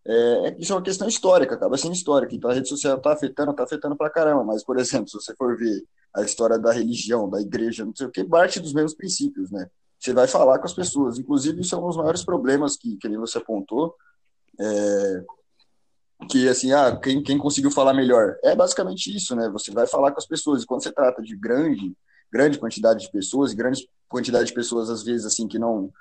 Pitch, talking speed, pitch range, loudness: 140 Hz, 225 wpm, 115-165 Hz, -22 LUFS